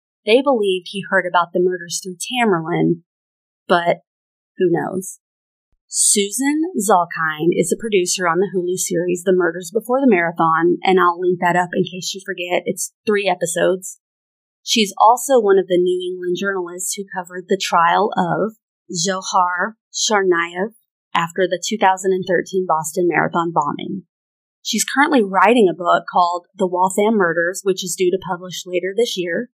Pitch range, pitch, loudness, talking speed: 175-195 Hz, 185 Hz, -18 LUFS, 155 wpm